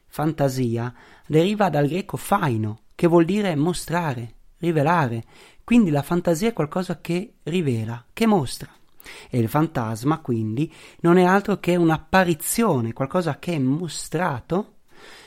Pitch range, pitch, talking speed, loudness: 135-180 Hz, 160 Hz, 125 wpm, -22 LUFS